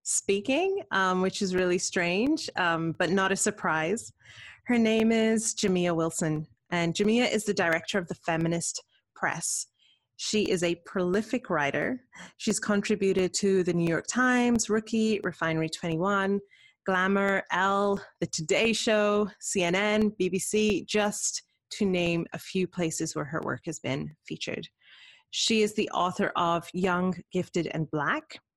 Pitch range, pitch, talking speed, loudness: 175-215 Hz, 195 Hz, 145 wpm, -27 LUFS